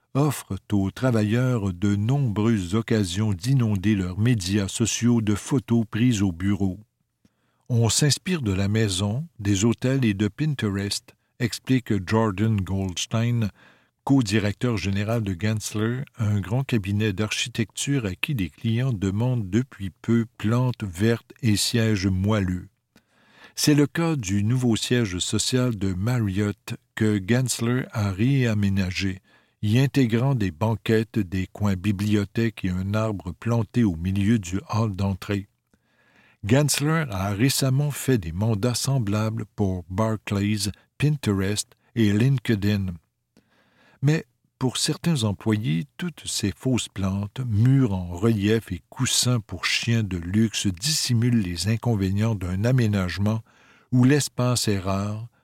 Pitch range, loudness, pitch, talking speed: 100-125 Hz, -24 LUFS, 110 Hz, 125 wpm